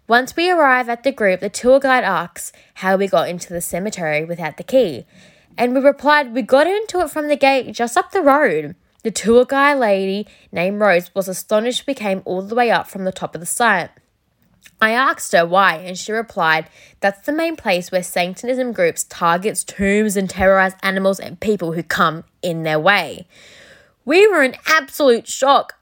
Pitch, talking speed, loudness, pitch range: 215 Hz, 195 wpm, -17 LUFS, 185-265 Hz